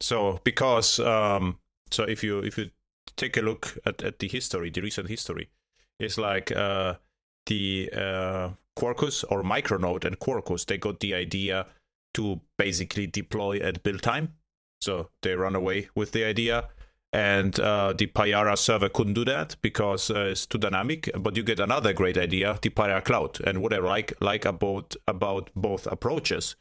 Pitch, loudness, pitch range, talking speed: 100 Hz, -27 LUFS, 95-110 Hz, 170 wpm